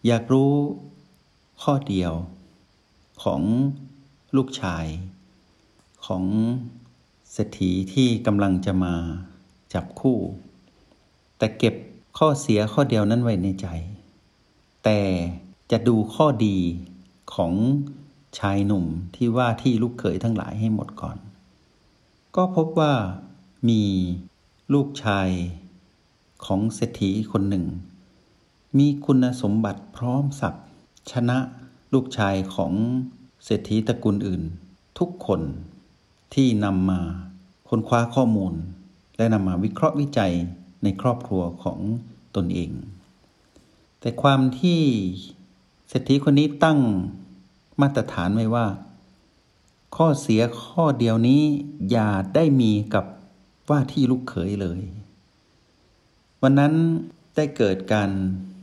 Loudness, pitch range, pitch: -23 LUFS, 95-130 Hz, 105 Hz